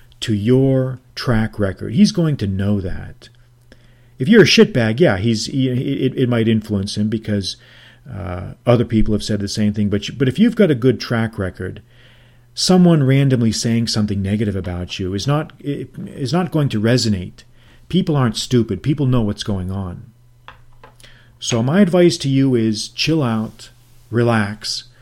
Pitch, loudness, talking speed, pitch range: 120 Hz, -17 LUFS, 175 wpm, 110-130 Hz